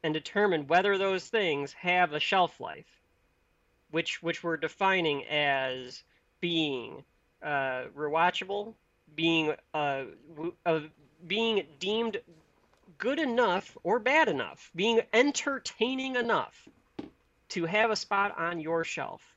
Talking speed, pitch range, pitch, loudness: 115 wpm, 155-210 Hz, 170 Hz, -29 LUFS